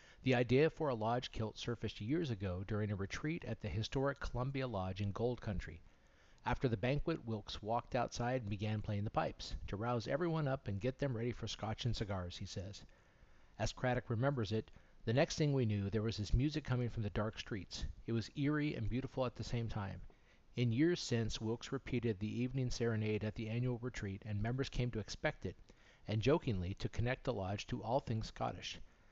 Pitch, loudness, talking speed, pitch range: 115 Hz, -40 LUFS, 205 wpm, 105-130 Hz